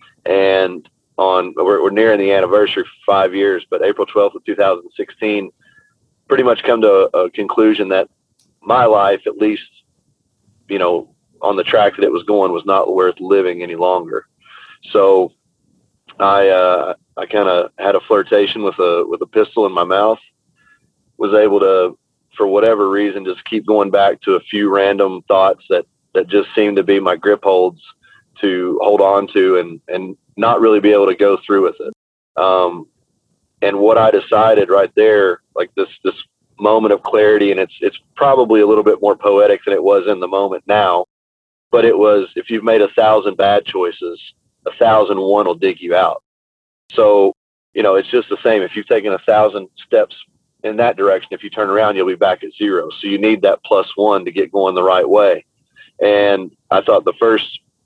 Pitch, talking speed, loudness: 110 Hz, 195 wpm, -14 LUFS